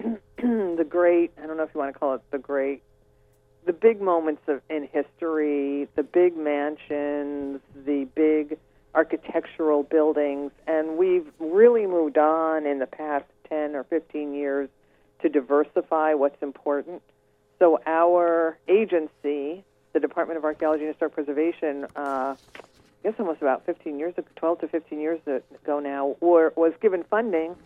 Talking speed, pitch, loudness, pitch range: 145 wpm, 155 Hz, -25 LUFS, 140-165 Hz